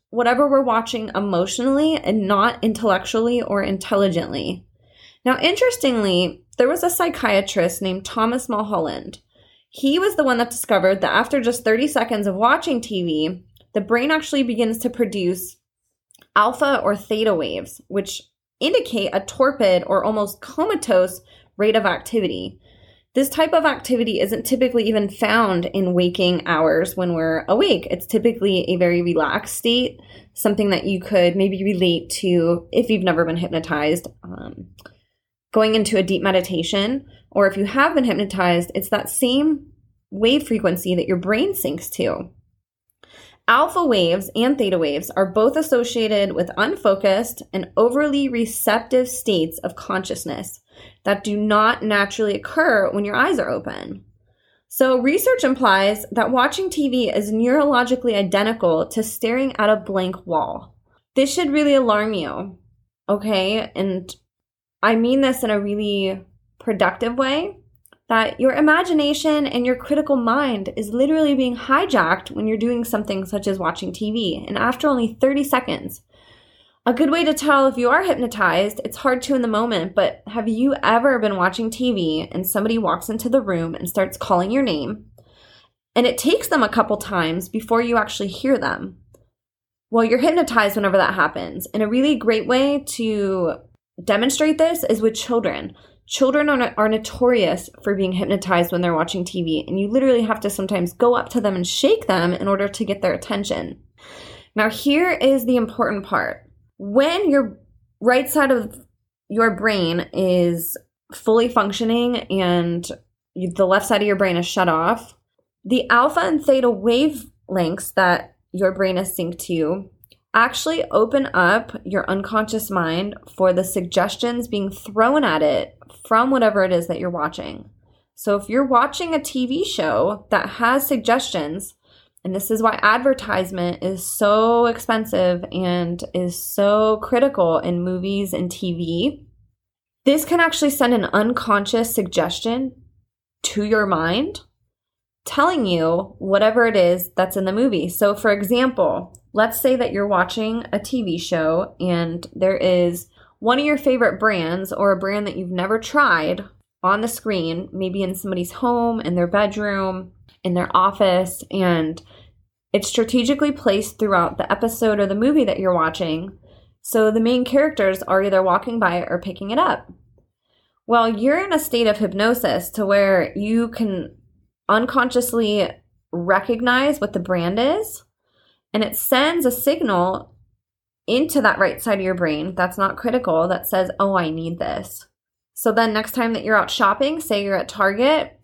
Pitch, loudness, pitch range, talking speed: 210 Hz, -19 LUFS, 185-245 Hz, 155 wpm